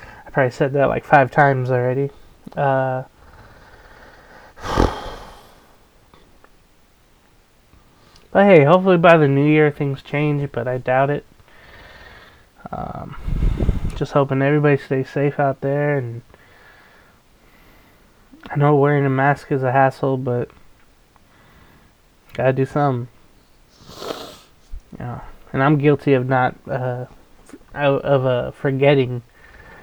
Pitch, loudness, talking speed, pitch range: 140 Hz, -18 LUFS, 105 wpm, 130-145 Hz